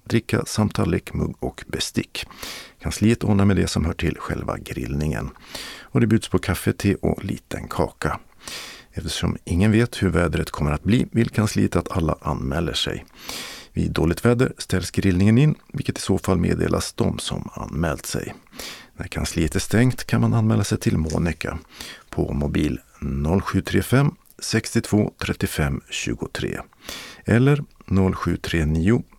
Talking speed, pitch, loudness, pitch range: 145 wpm, 100 Hz, -23 LUFS, 85-115 Hz